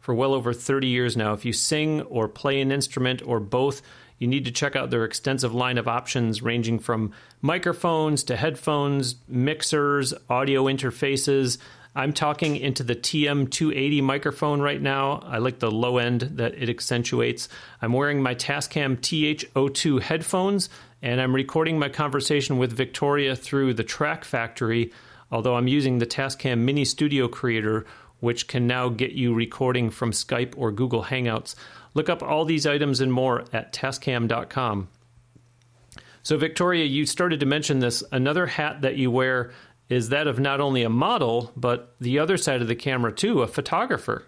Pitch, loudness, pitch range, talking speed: 130 Hz, -24 LUFS, 120-145 Hz, 165 wpm